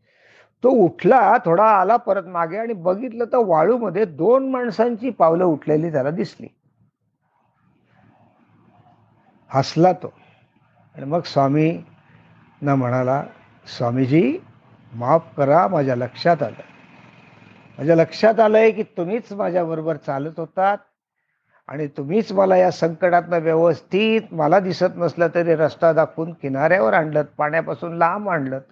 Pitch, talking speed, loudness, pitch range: 165 Hz, 115 wpm, -19 LUFS, 145-195 Hz